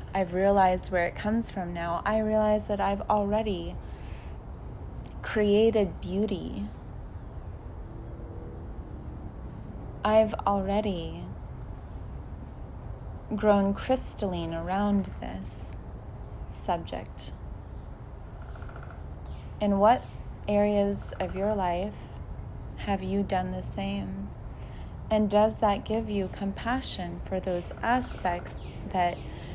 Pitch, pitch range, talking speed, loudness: 200 Hz, 175-210 Hz, 85 wpm, -28 LUFS